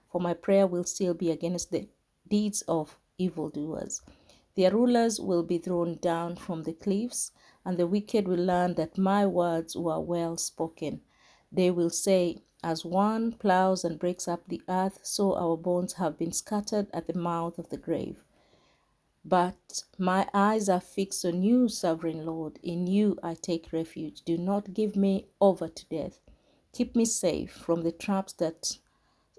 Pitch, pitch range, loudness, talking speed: 180 Hz, 170-195 Hz, -29 LUFS, 165 wpm